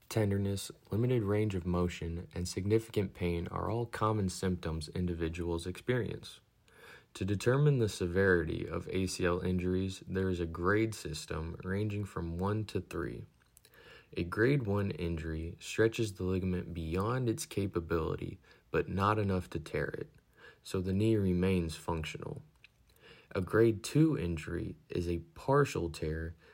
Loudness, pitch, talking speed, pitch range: -34 LUFS, 95 Hz, 135 wpm, 85-105 Hz